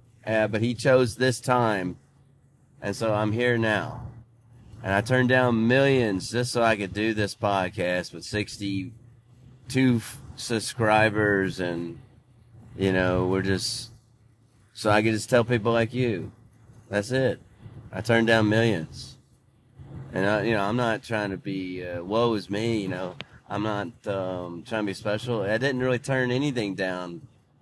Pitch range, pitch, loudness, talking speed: 100-125 Hz, 115 Hz, -25 LUFS, 160 wpm